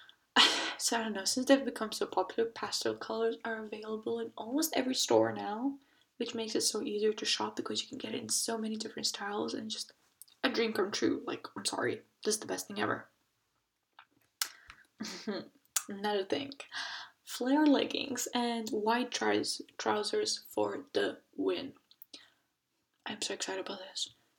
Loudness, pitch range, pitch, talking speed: -33 LUFS, 220-260 Hz, 230 Hz, 160 wpm